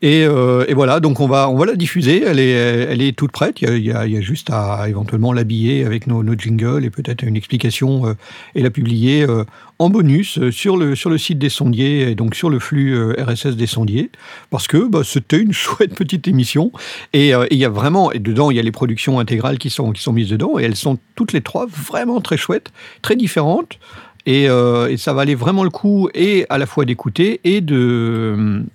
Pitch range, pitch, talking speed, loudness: 115-150 Hz, 135 Hz, 240 wpm, -16 LUFS